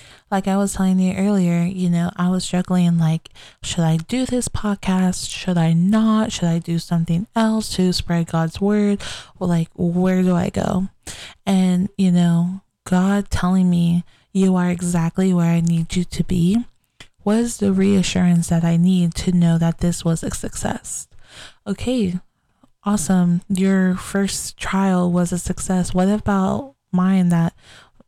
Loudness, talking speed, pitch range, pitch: -19 LUFS, 160 wpm, 170-195 Hz, 185 Hz